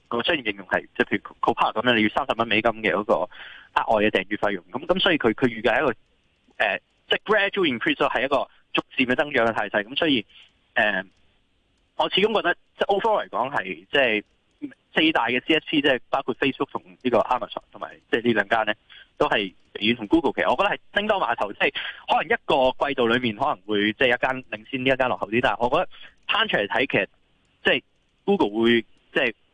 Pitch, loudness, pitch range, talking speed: 125 Hz, -23 LUFS, 110-140 Hz, 425 characters per minute